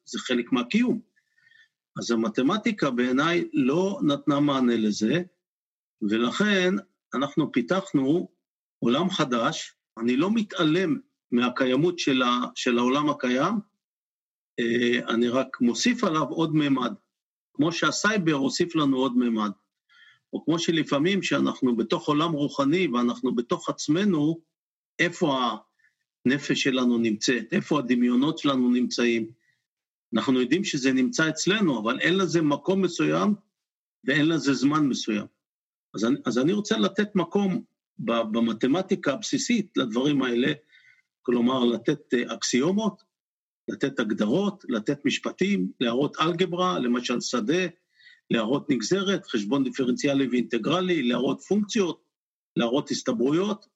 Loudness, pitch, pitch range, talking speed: -25 LUFS, 150 Hz, 125-195 Hz, 110 wpm